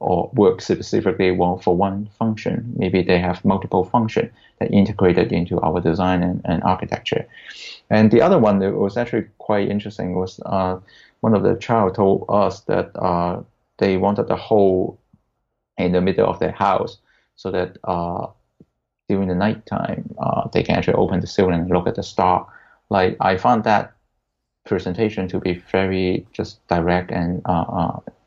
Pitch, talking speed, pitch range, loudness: 95 Hz, 170 wpm, 90-100 Hz, -20 LUFS